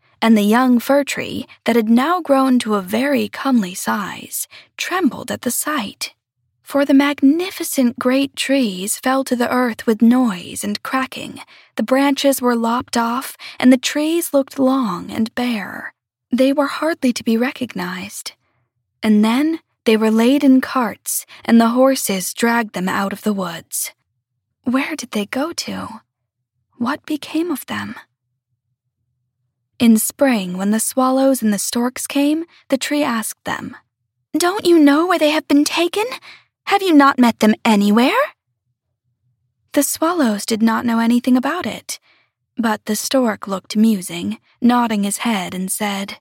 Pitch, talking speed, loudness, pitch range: 240 Hz, 155 wpm, -17 LUFS, 205-275 Hz